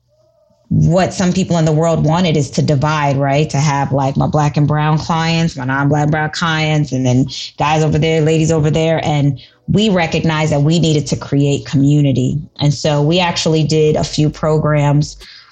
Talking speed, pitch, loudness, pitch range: 190 wpm, 155 Hz, -14 LUFS, 145-160 Hz